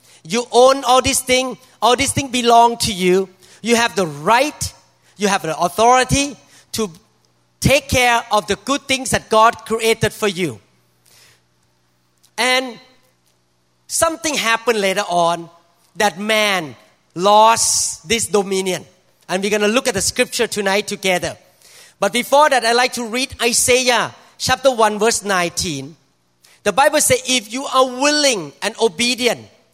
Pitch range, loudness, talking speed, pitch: 170-245 Hz, -16 LUFS, 145 wpm, 215 Hz